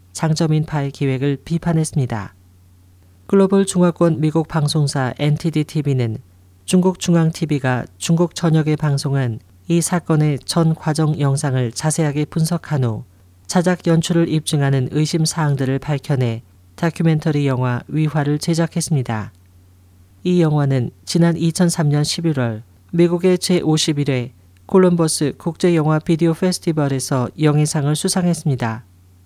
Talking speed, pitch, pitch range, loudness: 285 characters per minute, 150 Hz, 125-165 Hz, -18 LUFS